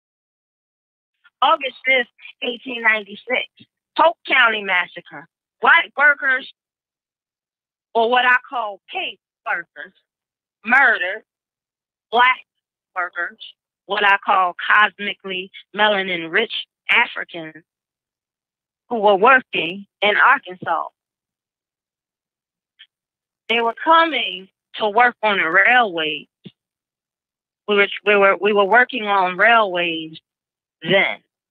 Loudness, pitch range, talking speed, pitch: -17 LUFS, 185-250 Hz, 95 wpm, 210 Hz